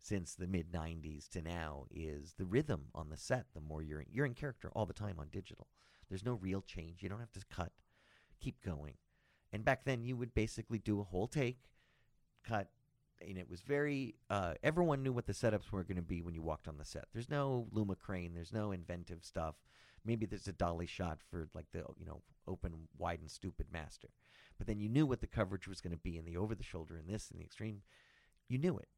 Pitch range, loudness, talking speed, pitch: 85-115 Hz, -42 LUFS, 235 wpm, 95 Hz